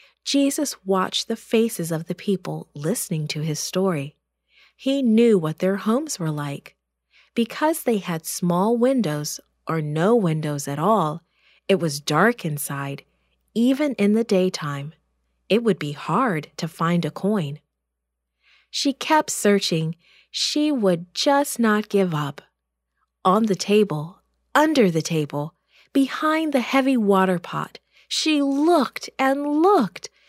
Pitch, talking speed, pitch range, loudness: 190 Hz, 135 wpm, 155-240 Hz, -22 LUFS